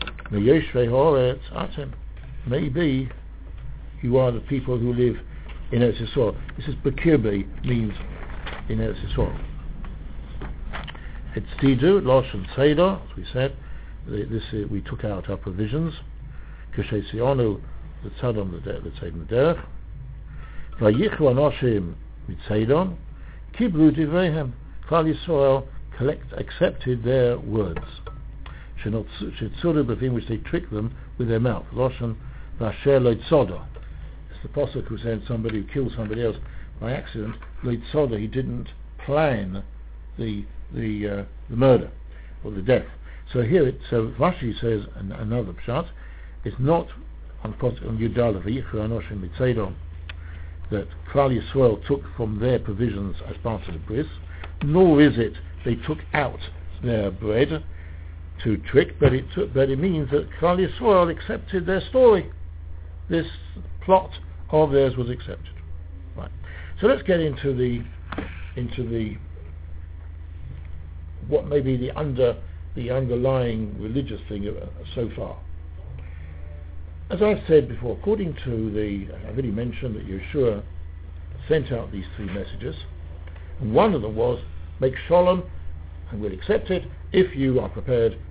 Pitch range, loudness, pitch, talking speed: 80-130 Hz, -24 LUFS, 110 Hz, 130 wpm